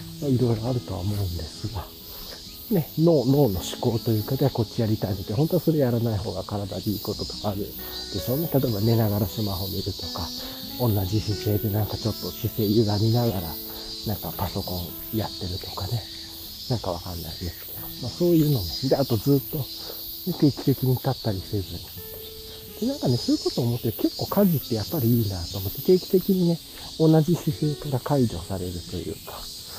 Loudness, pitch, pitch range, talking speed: -25 LUFS, 110 Hz, 95-135 Hz, 400 characters per minute